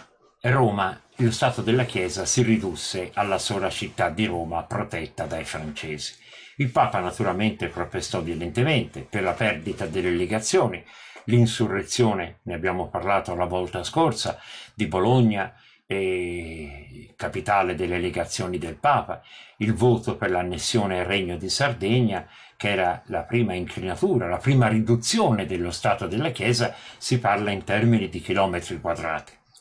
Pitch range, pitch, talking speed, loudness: 90-120 Hz, 105 Hz, 135 wpm, -24 LUFS